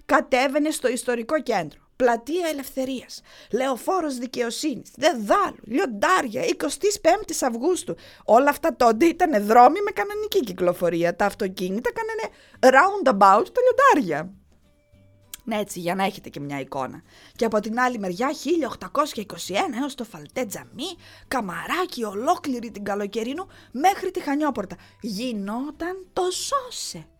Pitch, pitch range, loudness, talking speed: 255 Hz, 205-325 Hz, -23 LUFS, 120 wpm